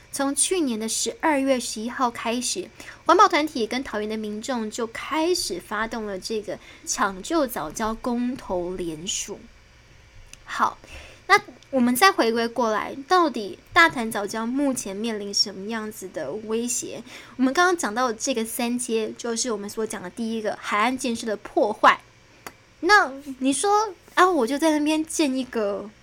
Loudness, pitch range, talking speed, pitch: -23 LUFS, 215-285 Hz, 235 characters per minute, 240 Hz